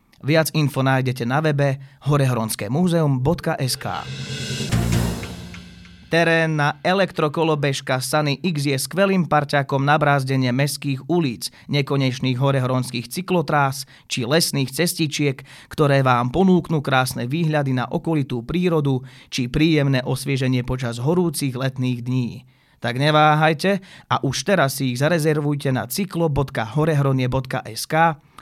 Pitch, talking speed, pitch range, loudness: 140 Hz, 105 wpm, 130-155 Hz, -20 LUFS